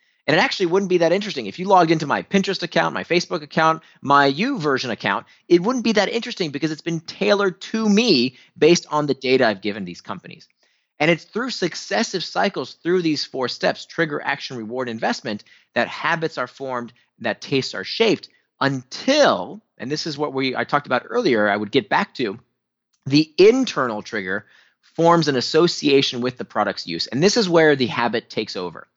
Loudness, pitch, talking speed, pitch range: -20 LUFS, 160 Hz, 180 wpm, 130-195 Hz